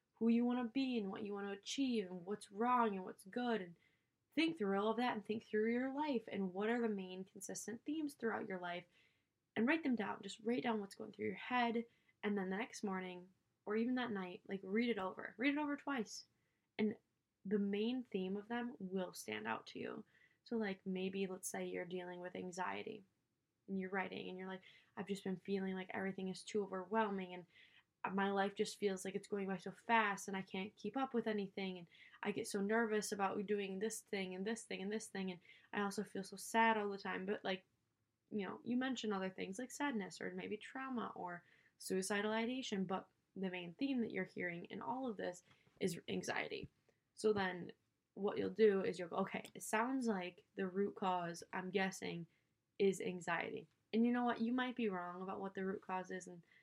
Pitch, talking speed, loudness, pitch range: 200 Hz, 220 wpm, -42 LUFS, 190-225 Hz